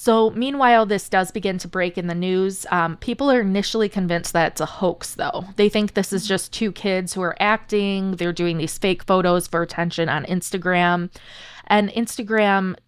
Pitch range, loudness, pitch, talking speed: 175-210 Hz, -21 LUFS, 190 Hz, 190 wpm